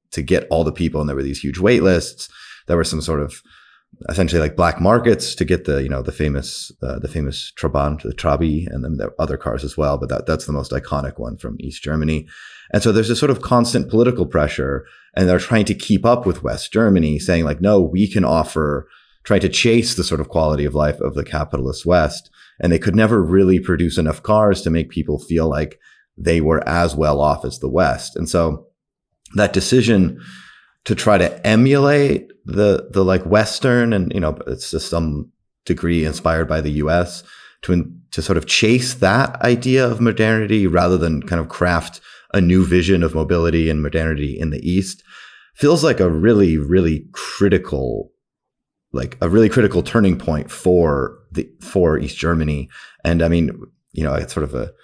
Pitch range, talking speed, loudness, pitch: 75-95 Hz, 200 wpm, -18 LUFS, 85 Hz